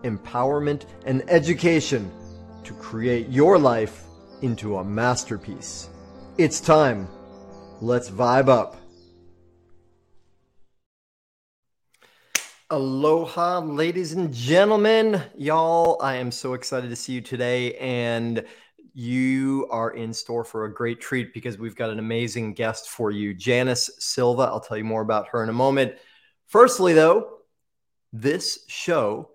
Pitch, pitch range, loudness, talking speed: 120 Hz, 110-140 Hz, -22 LUFS, 125 wpm